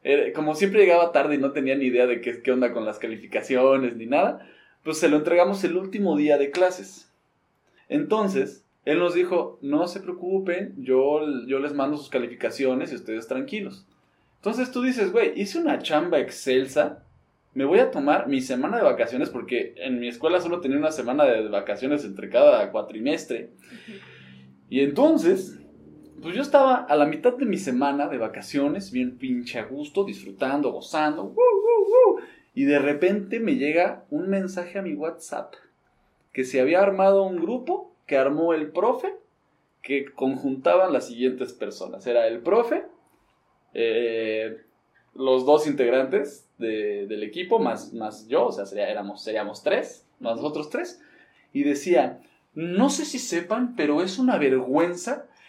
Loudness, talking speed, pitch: -24 LUFS, 160 wpm, 165 Hz